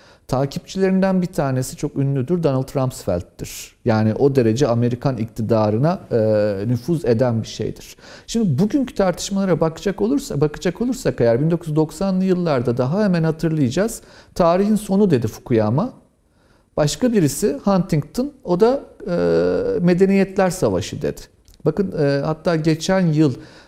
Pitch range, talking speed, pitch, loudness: 125-190 Hz, 115 wpm, 155 Hz, -19 LUFS